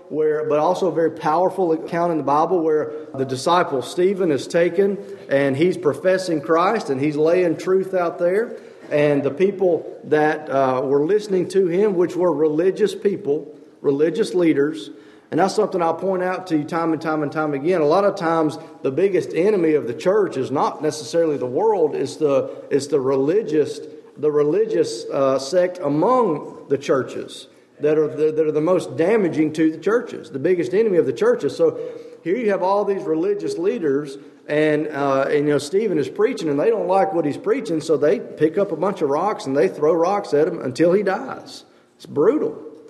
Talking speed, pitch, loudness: 195 wpm, 175 Hz, -20 LUFS